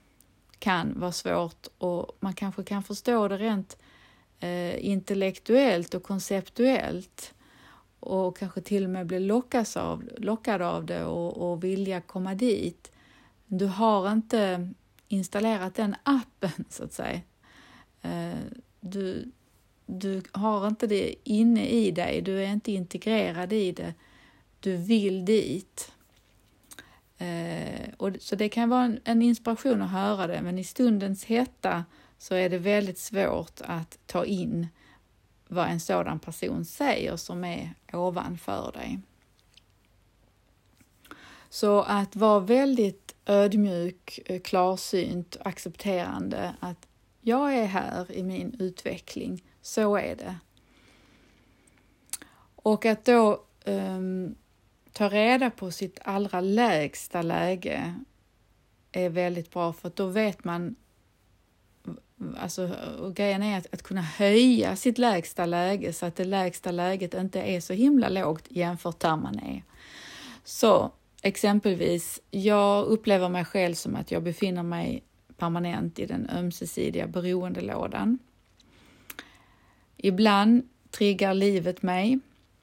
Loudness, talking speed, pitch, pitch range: -27 LUFS, 120 wpm, 190 Hz, 175-215 Hz